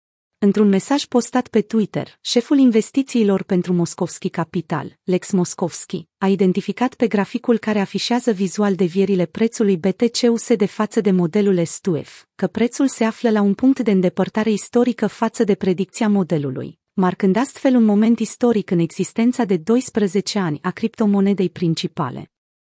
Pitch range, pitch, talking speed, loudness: 185-230 Hz, 200 Hz, 145 wpm, -19 LUFS